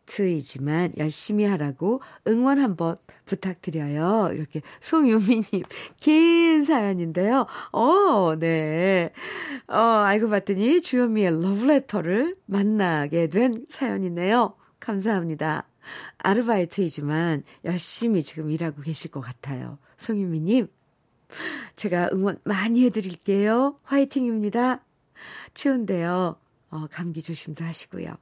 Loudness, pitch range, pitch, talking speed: -23 LUFS, 165-240 Hz, 195 Hz, 255 characters per minute